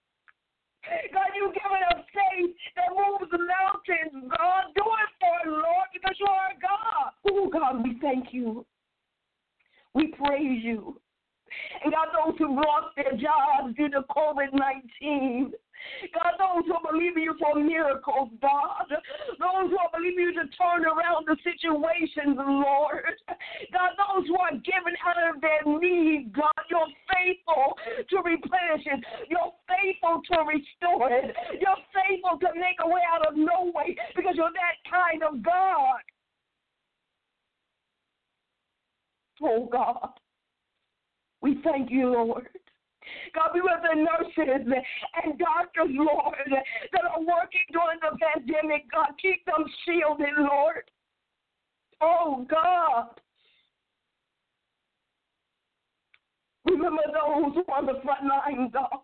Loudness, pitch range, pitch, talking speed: -26 LUFS, 295-360 Hz, 330 Hz, 130 wpm